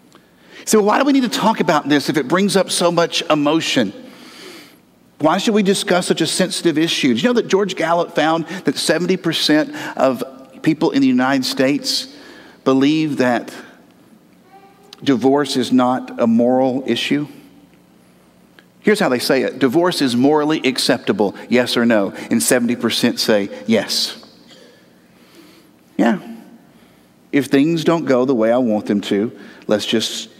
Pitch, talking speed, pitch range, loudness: 155 Hz, 150 wpm, 130-185 Hz, -17 LUFS